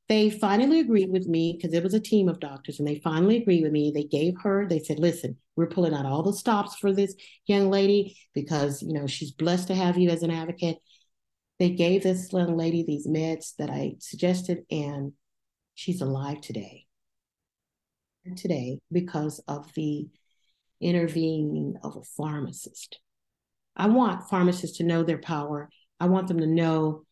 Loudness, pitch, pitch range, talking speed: -26 LUFS, 165 Hz, 150-185 Hz, 175 wpm